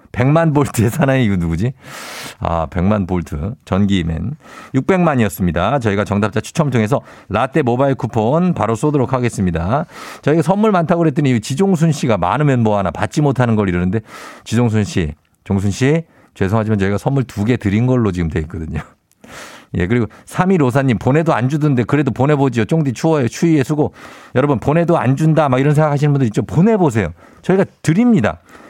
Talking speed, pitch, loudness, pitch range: 380 characters per minute, 125 Hz, -16 LUFS, 105-150 Hz